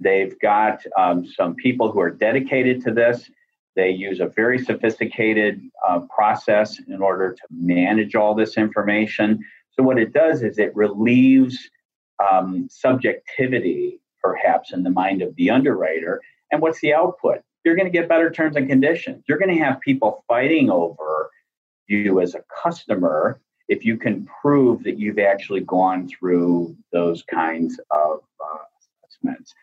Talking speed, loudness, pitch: 155 wpm, -20 LUFS, 115 Hz